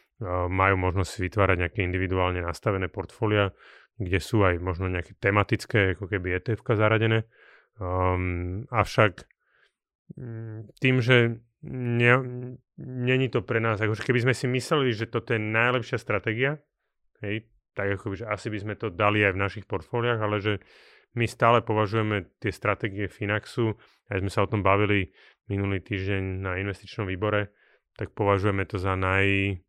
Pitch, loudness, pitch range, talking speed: 105 Hz, -26 LUFS, 95-115 Hz, 150 wpm